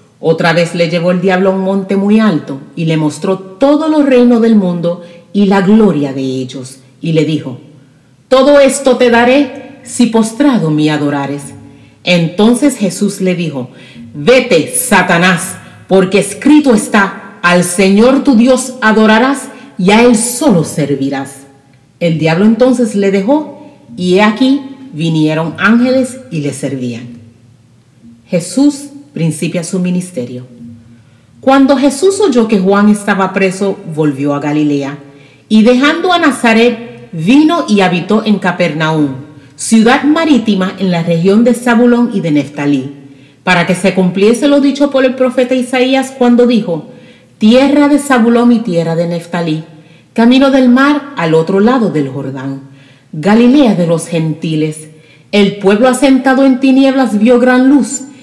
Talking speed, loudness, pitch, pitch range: 140 wpm, -10 LUFS, 195 Hz, 155-250 Hz